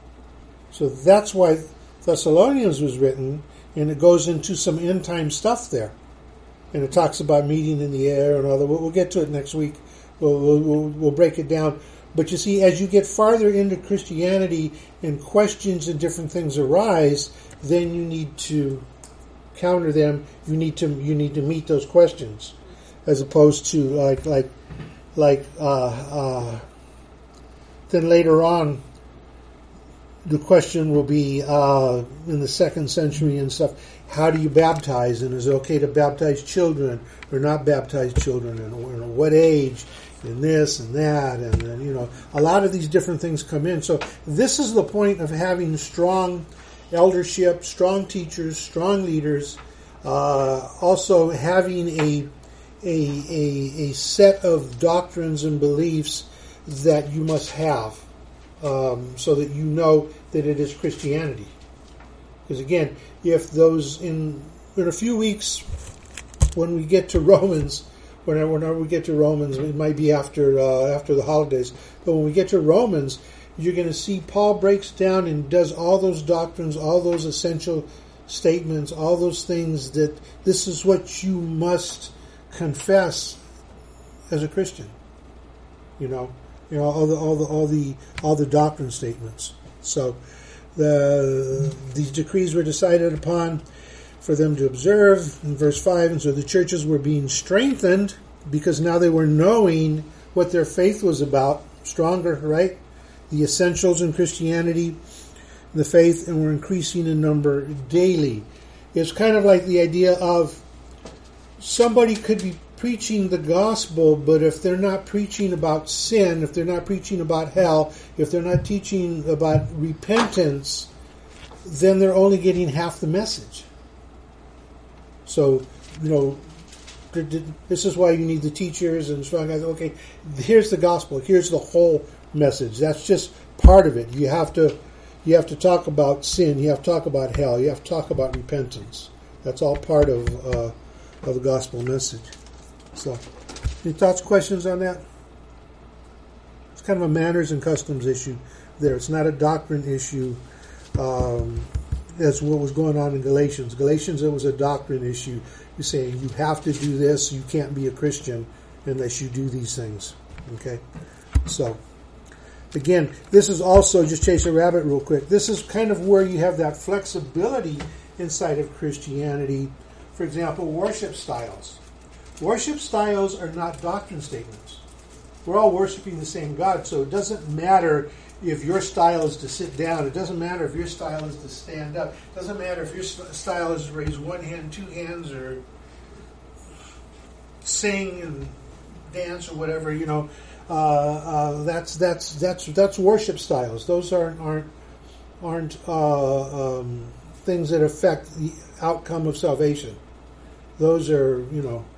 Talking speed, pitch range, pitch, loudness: 160 wpm, 135-175 Hz, 155 Hz, -21 LUFS